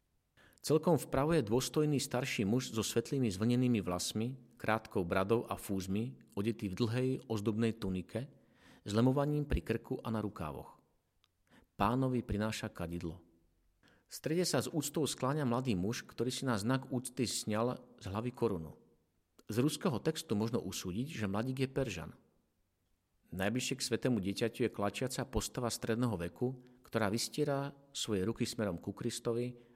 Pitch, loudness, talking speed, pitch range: 115 Hz, -36 LUFS, 145 wpm, 100-130 Hz